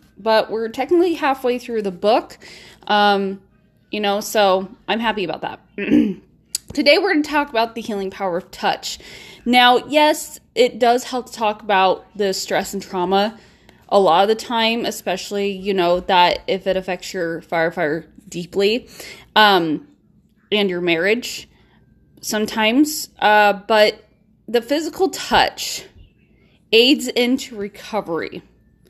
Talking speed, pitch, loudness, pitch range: 135 wpm, 210 Hz, -18 LUFS, 195-245 Hz